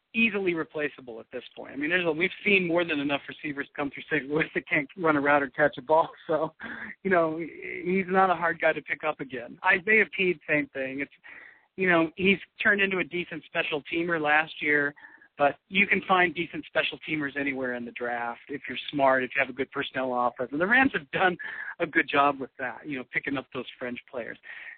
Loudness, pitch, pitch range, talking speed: -26 LUFS, 155 Hz, 140-175 Hz, 230 wpm